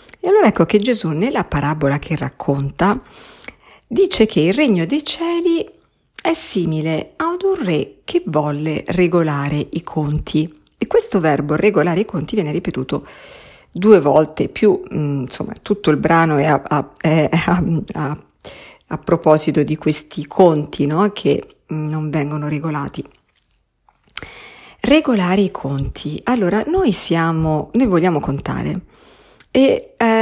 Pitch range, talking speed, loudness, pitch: 150-220 Hz, 135 wpm, -17 LUFS, 165 Hz